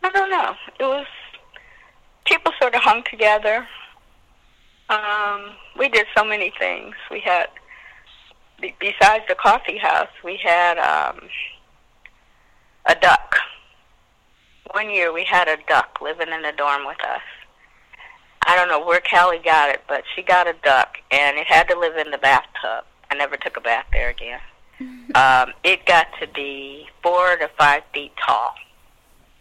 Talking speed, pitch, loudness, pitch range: 155 wpm, 175 Hz, -18 LUFS, 155-215 Hz